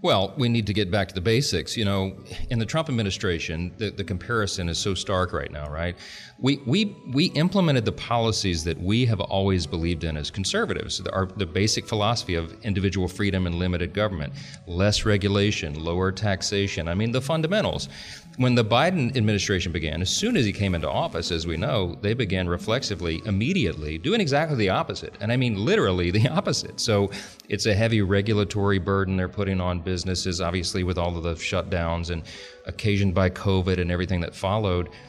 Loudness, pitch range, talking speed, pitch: -25 LUFS, 90-110 Hz, 185 wpm, 100 Hz